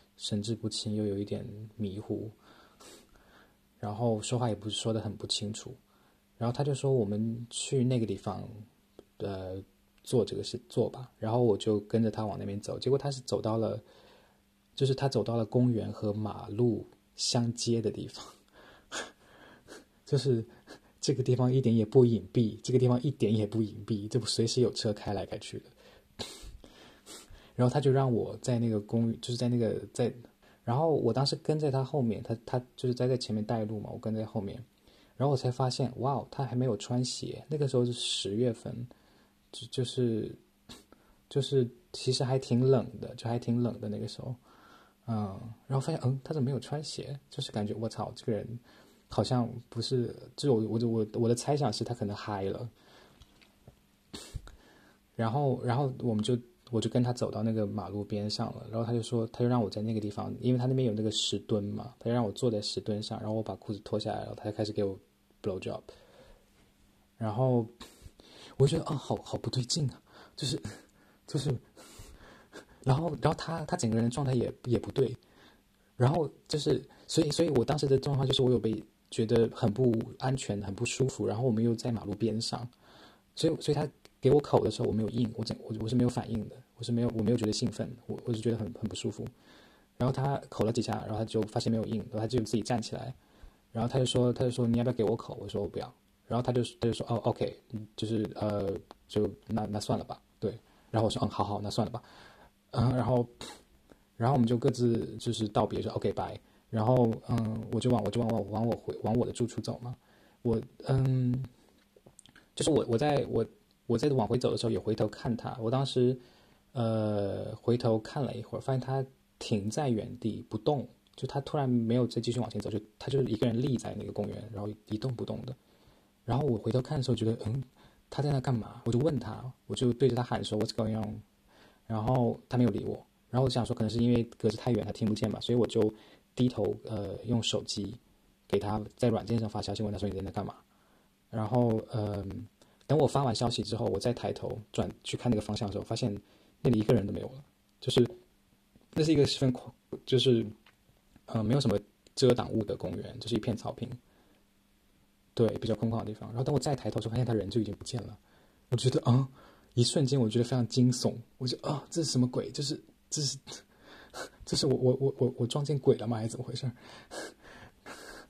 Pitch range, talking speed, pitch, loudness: 110-125 Hz, 300 characters per minute, 115 Hz, -32 LUFS